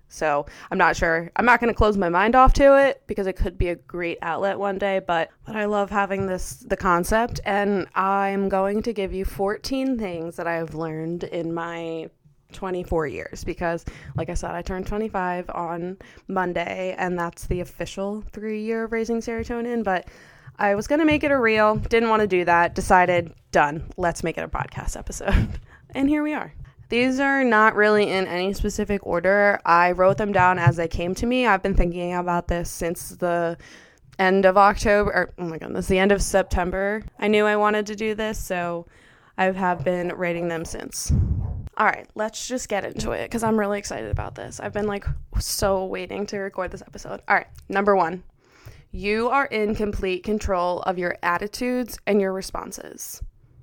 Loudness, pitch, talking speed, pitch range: -23 LUFS, 190 Hz, 195 wpm, 175-210 Hz